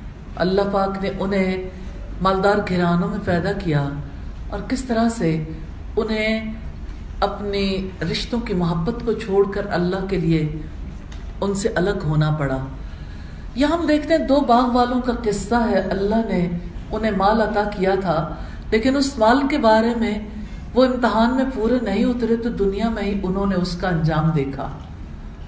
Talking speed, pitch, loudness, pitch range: 160 wpm, 200 Hz, -20 LUFS, 170-225 Hz